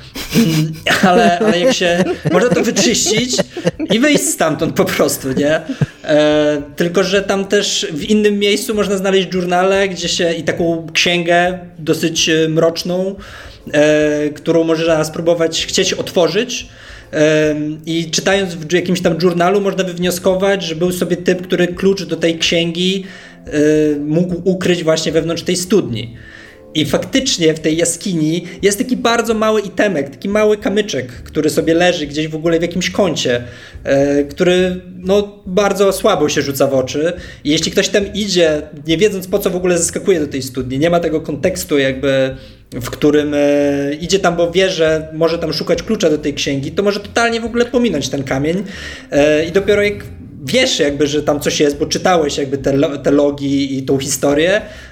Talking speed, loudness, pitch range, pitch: 165 wpm, -15 LUFS, 150-190 Hz, 170 Hz